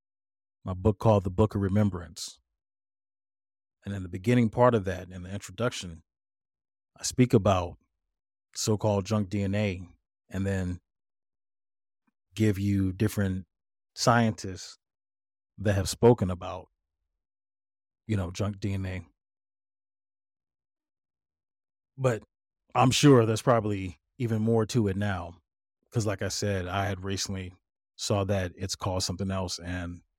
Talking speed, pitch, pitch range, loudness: 125 wpm, 100 Hz, 90-105 Hz, -28 LUFS